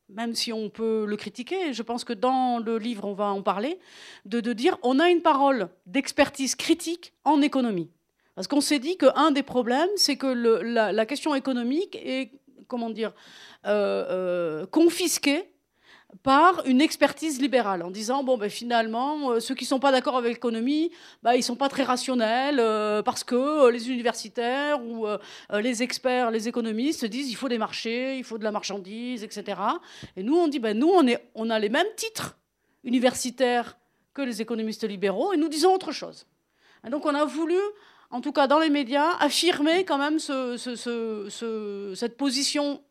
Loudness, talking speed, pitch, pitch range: -25 LUFS, 195 wpm, 255 Hz, 225-290 Hz